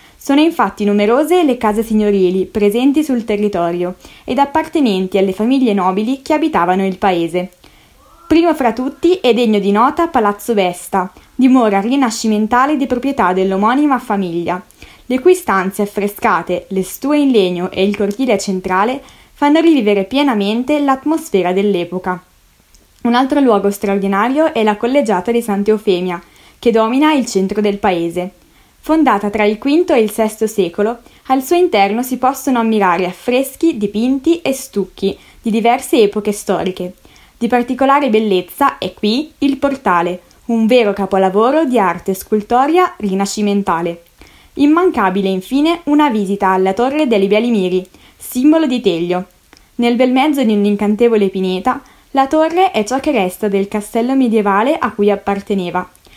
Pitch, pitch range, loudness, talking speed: 220 Hz, 195-265 Hz, -14 LUFS, 140 wpm